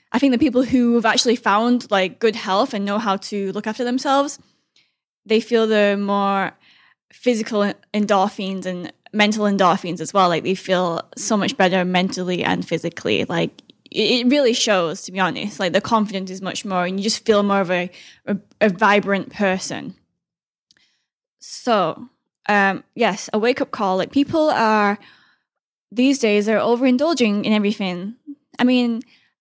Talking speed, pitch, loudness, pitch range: 160 wpm, 210 Hz, -19 LUFS, 190-235 Hz